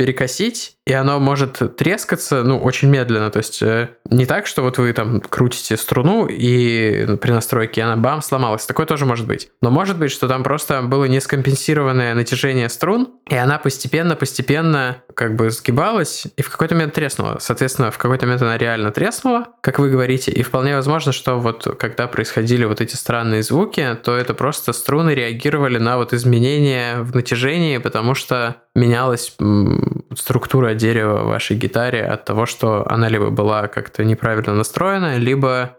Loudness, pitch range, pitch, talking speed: -17 LUFS, 115-140 Hz, 130 Hz, 165 wpm